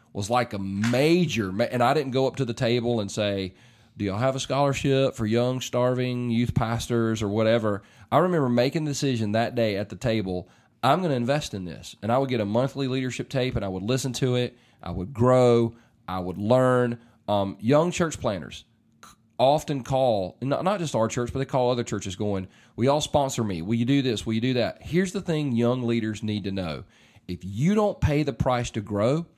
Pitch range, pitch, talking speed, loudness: 110-135 Hz, 120 Hz, 215 wpm, -25 LUFS